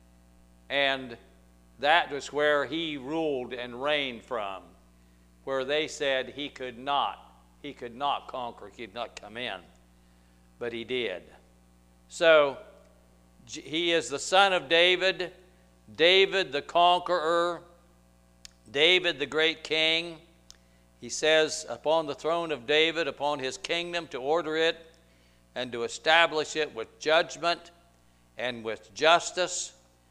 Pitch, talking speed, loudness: 140 Hz, 125 wpm, -27 LUFS